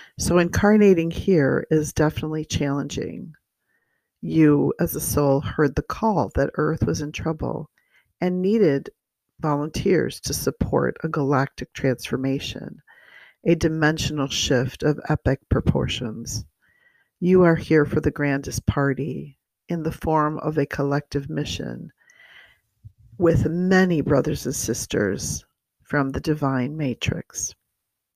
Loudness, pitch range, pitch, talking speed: -22 LUFS, 135-160 Hz, 150 Hz, 115 wpm